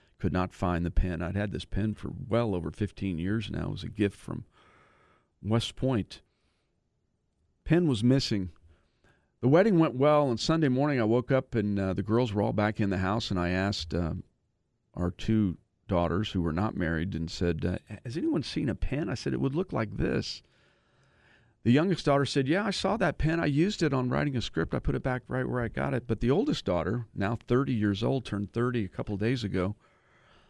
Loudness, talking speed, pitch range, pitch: -29 LUFS, 220 wpm, 90-125 Hz, 105 Hz